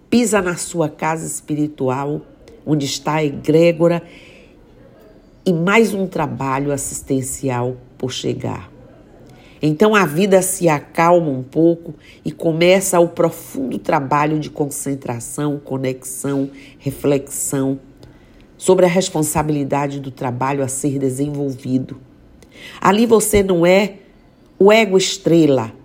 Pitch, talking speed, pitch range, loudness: 150 Hz, 105 wpm, 135-175 Hz, -17 LUFS